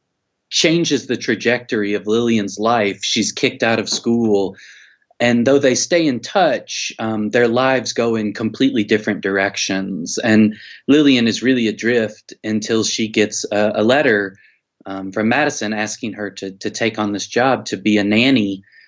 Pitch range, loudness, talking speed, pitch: 105-120 Hz, -17 LUFS, 160 wpm, 110 Hz